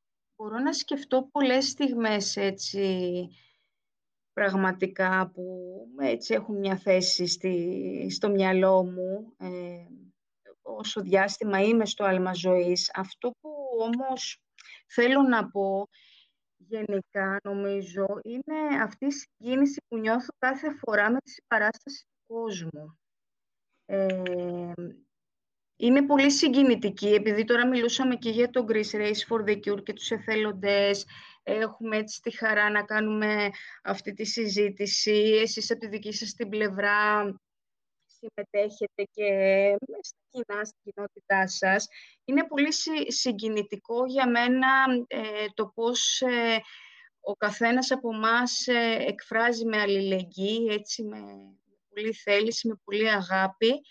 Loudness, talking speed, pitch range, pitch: -26 LUFS, 120 wpm, 195-240 Hz, 215 Hz